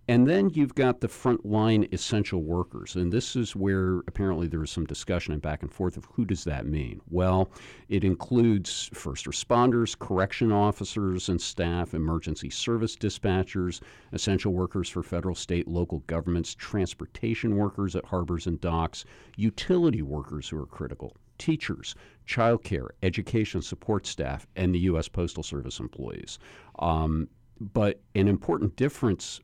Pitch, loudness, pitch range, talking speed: 95 Hz, -28 LUFS, 85-110 Hz, 145 wpm